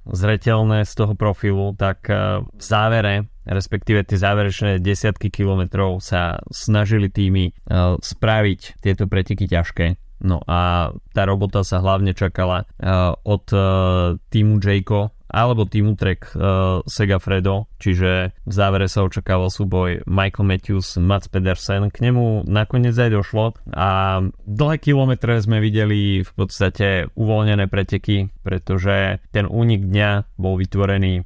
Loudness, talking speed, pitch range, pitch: -19 LUFS, 125 wpm, 95-105 Hz, 100 Hz